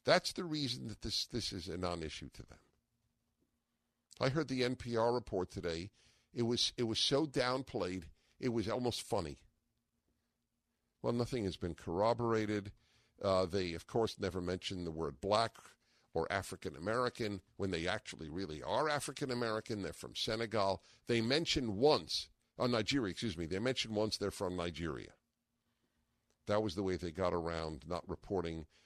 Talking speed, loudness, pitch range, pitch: 160 wpm, -37 LUFS, 90-120 Hz, 105 Hz